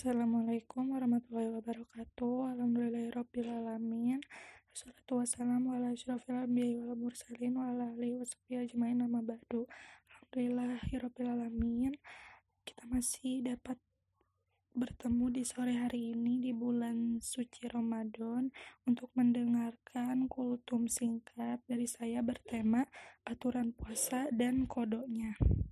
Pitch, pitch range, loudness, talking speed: 245 Hz, 235-250 Hz, -37 LUFS, 80 wpm